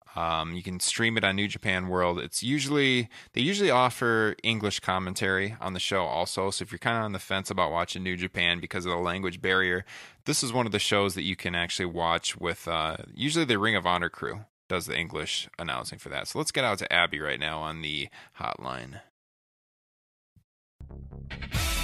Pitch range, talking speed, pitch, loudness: 85-110 Hz, 200 wpm, 95 Hz, -28 LUFS